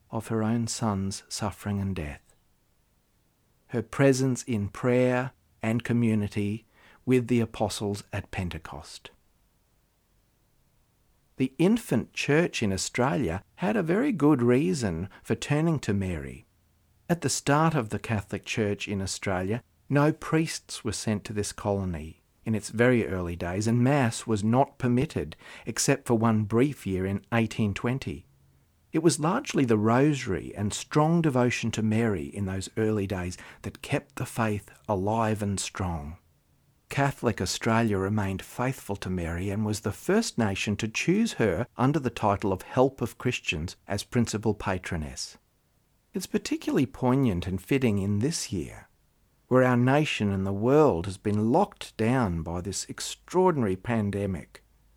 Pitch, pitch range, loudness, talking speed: 110 Hz, 95-125 Hz, -27 LUFS, 145 wpm